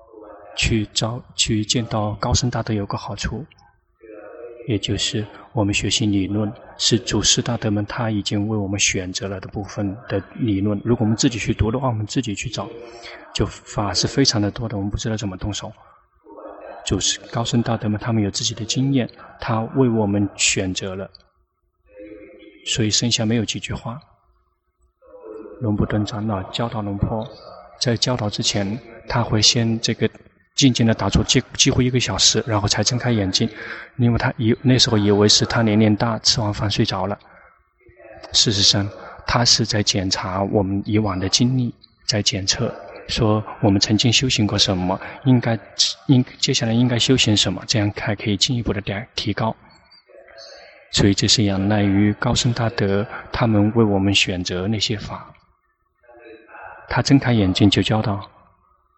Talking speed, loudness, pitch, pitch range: 250 characters per minute, -19 LUFS, 110 Hz, 100-120 Hz